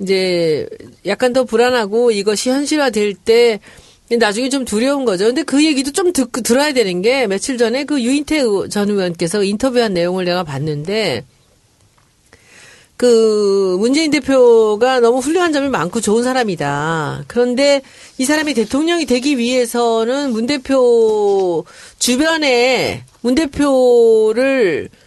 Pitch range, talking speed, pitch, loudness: 200-270 Hz, 275 characters per minute, 240 Hz, -15 LUFS